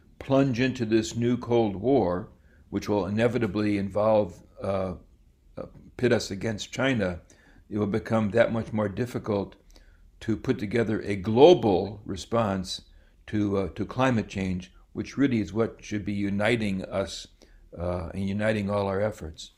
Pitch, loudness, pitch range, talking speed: 105 Hz, -27 LUFS, 90-115 Hz, 145 wpm